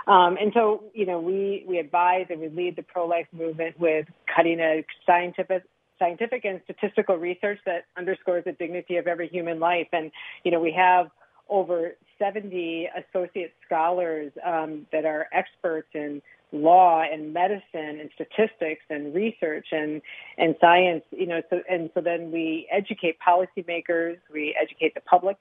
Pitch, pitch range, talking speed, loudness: 175 Hz, 165-185 Hz, 160 wpm, -25 LUFS